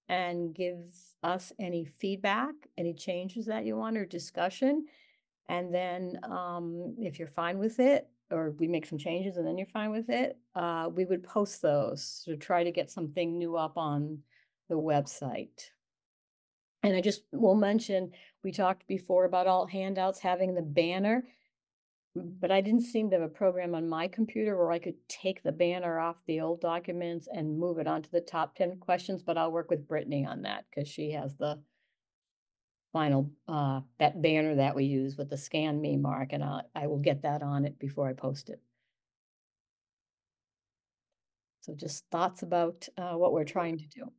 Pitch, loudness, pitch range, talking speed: 170 Hz, -32 LUFS, 150-185 Hz, 180 wpm